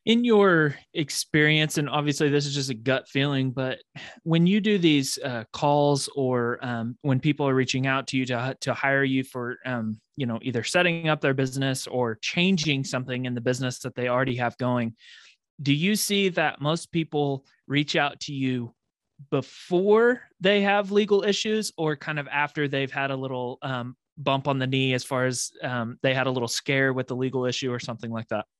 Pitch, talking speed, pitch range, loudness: 135 Hz, 200 wpm, 125-155 Hz, -25 LUFS